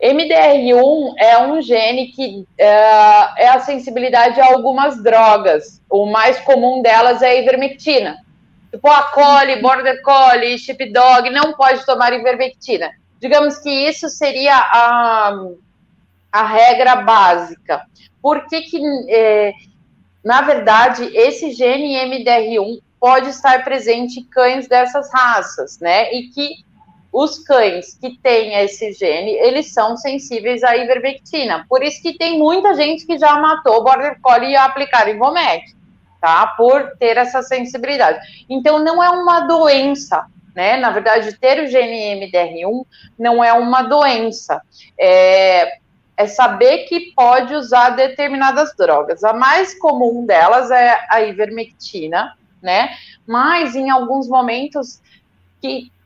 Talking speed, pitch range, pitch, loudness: 130 wpm, 230-280 Hz, 255 Hz, -13 LUFS